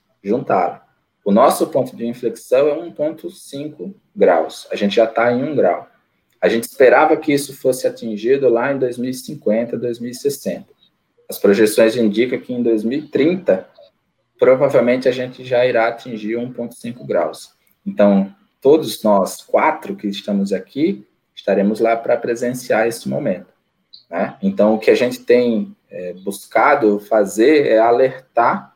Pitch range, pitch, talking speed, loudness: 110-135 Hz, 120 Hz, 140 wpm, -17 LUFS